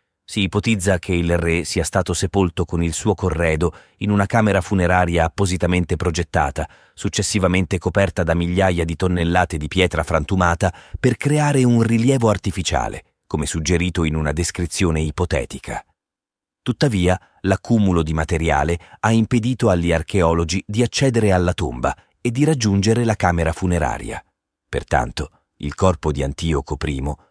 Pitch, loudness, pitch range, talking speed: 90 Hz, -19 LUFS, 85-100 Hz, 135 wpm